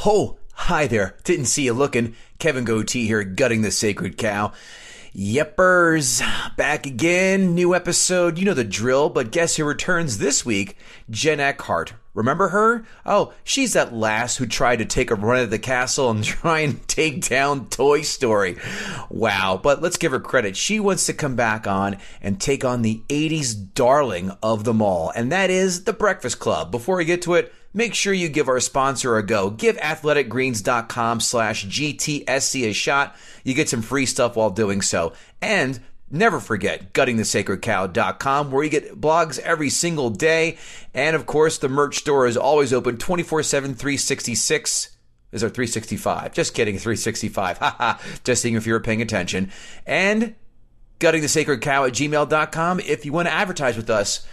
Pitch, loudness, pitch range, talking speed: 140 Hz, -20 LUFS, 115-165 Hz, 170 wpm